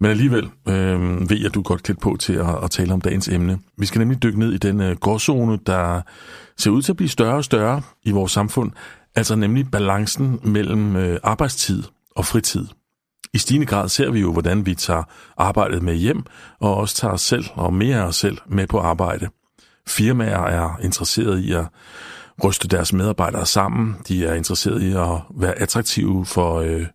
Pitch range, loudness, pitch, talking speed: 90-110 Hz, -20 LUFS, 100 Hz, 195 wpm